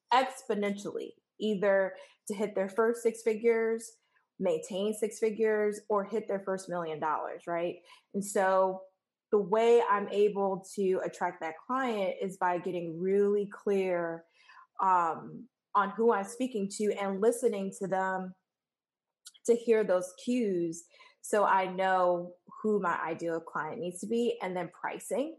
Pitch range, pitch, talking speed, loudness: 185-230 Hz, 205 Hz, 140 wpm, -31 LUFS